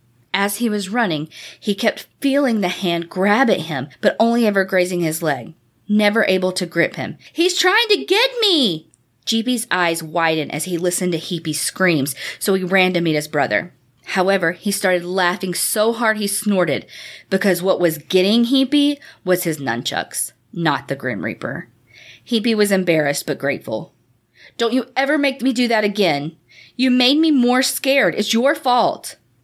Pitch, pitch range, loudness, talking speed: 190 Hz, 165-235 Hz, -18 LUFS, 175 wpm